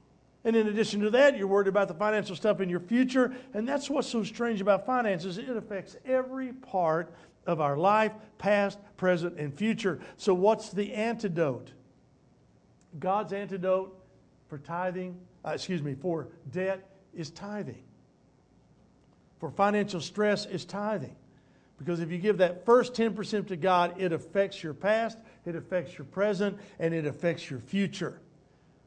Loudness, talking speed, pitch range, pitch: -29 LUFS, 155 wpm, 170-210 Hz, 195 Hz